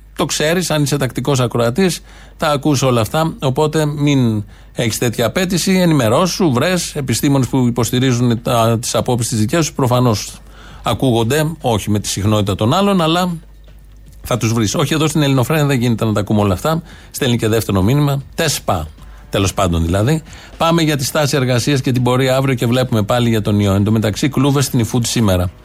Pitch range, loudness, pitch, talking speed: 115-150 Hz, -15 LUFS, 125 Hz, 180 wpm